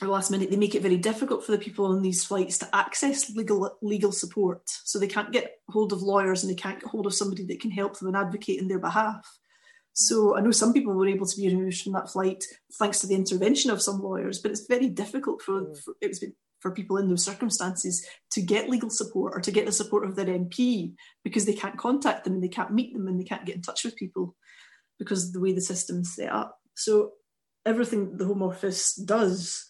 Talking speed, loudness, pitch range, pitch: 240 wpm, -27 LUFS, 190-220 Hz, 200 Hz